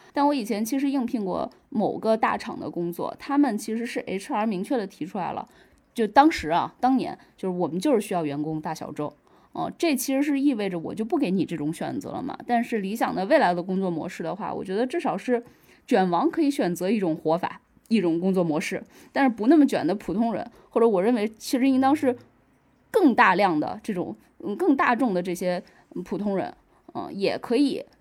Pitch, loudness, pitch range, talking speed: 225 Hz, -25 LUFS, 180-270 Hz, 315 characters per minute